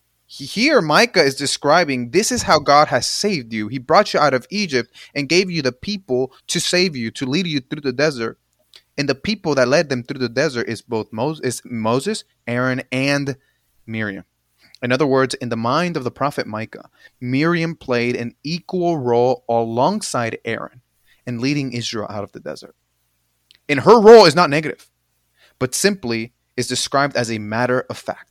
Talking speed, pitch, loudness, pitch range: 180 wpm, 130 Hz, -18 LUFS, 115-155 Hz